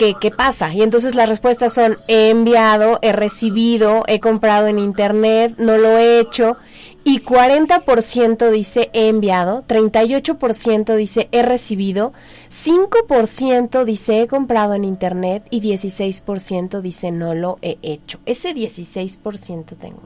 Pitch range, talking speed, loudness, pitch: 205-235 Hz, 135 wpm, -15 LUFS, 220 Hz